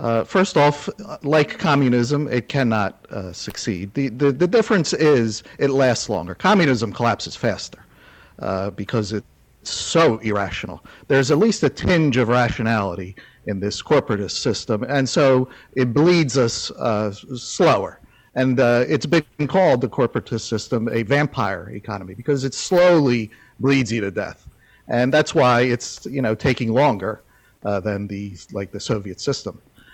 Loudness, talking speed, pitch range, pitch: -20 LUFS, 150 wpm, 110-145 Hz, 125 Hz